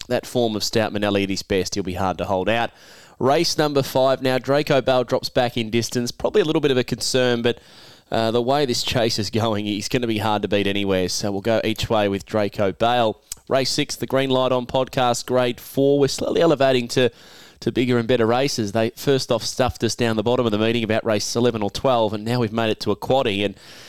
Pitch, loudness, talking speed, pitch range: 120 Hz, -21 LUFS, 245 wpm, 105-130 Hz